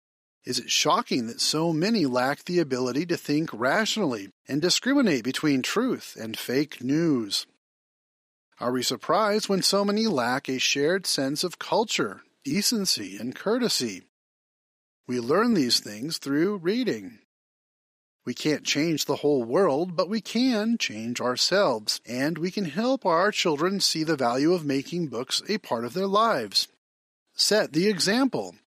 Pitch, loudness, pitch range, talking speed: 175 Hz, -25 LUFS, 140-210 Hz, 150 wpm